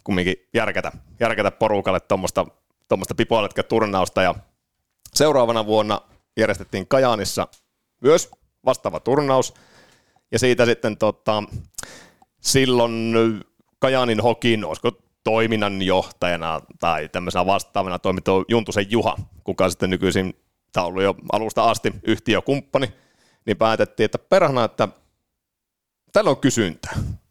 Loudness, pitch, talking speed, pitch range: -21 LUFS, 110 Hz, 110 wpm, 95-115 Hz